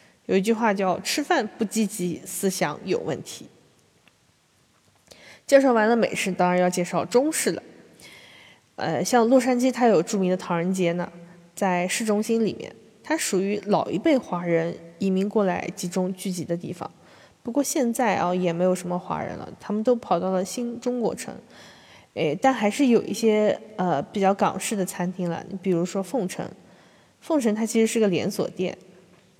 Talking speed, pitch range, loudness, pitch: 250 characters per minute, 180-225 Hz, -24 LUFS, 195 Hz